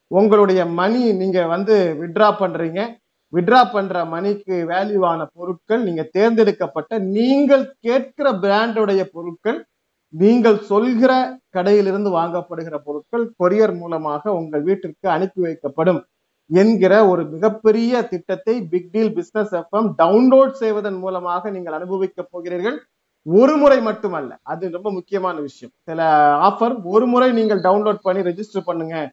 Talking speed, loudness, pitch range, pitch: 115 wpm, -18 LUFS, 175-220 Hz, 195 Hz